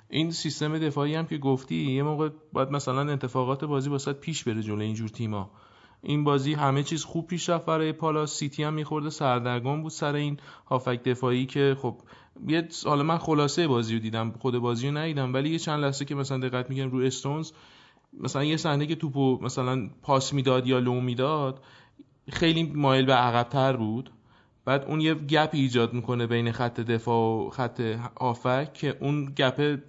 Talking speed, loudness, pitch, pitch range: 180 wpm, -27 LUFS, 135 Hz, 125-150 Hz